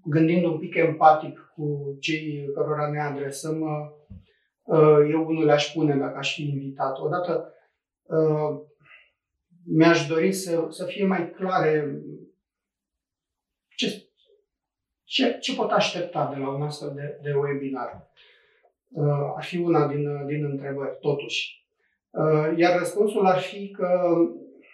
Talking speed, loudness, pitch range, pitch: 120 wpm, -24 LUFS, 145-175 Hz, 155 Hz